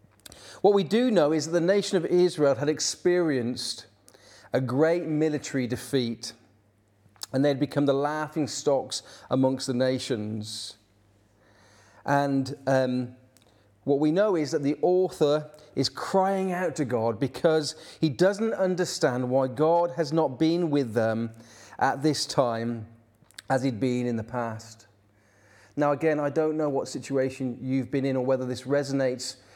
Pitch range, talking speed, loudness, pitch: 115-155 Hz, 145 wpm, -26 LUFS, 135 Hz